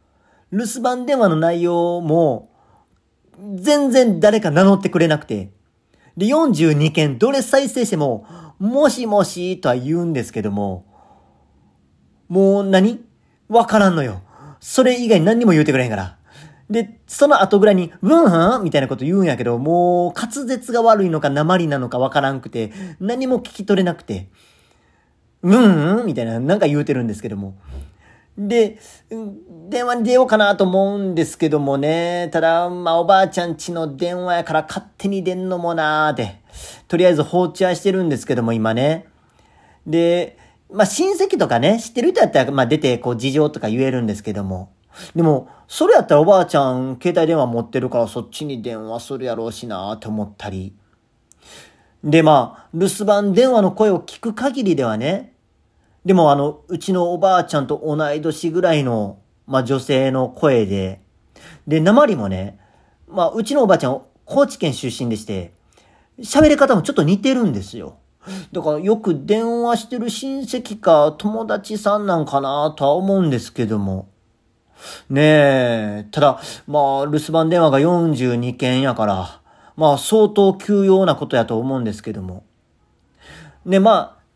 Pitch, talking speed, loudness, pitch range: 160 Hz, 320 characters per minute, -17 LUFS, 125-195 Hz